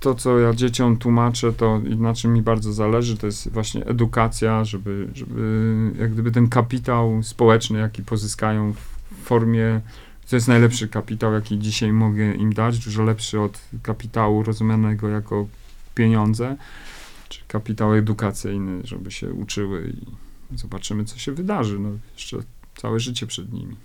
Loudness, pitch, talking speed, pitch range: -21 LUFS, 110 Hz, 150 wpm, 105-115 Hz